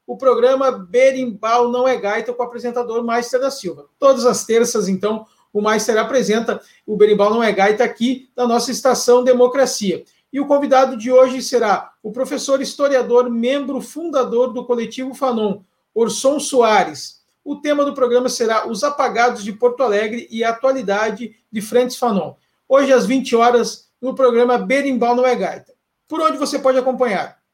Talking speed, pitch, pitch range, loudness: 165 wpm, 245 Hz, 230-260 Hz, -17 LUFS